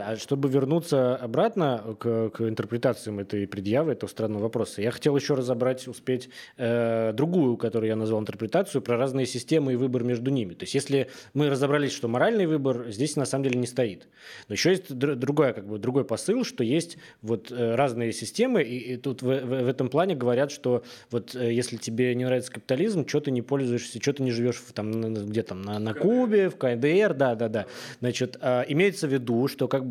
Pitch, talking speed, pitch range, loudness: 125 Hz, 200 wpm, 115-140 Hz, -26 LUFS